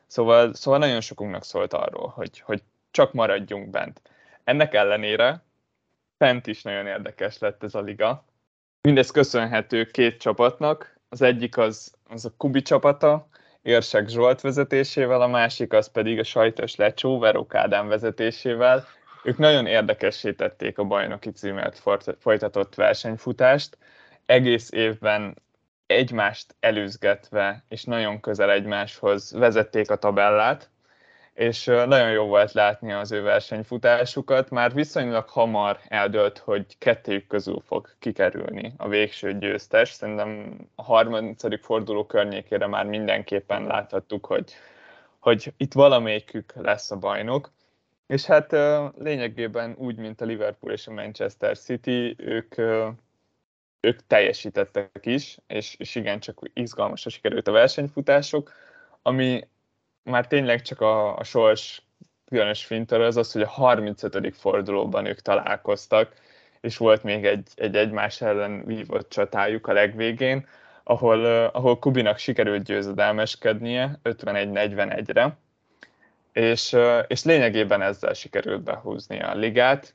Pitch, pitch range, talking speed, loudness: 115 Hz, 105-130 Hz, 120 wpm, -23 LUFS